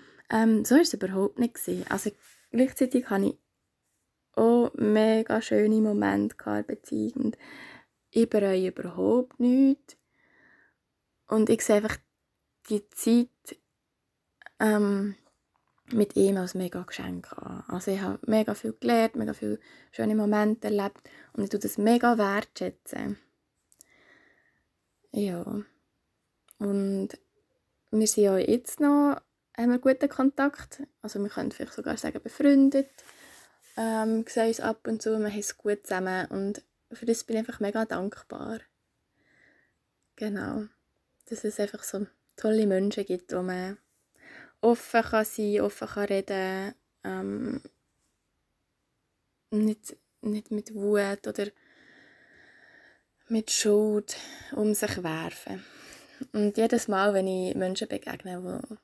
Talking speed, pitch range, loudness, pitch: 125 wpm, 195-235 Hz, -27 LUFS, 215 Hz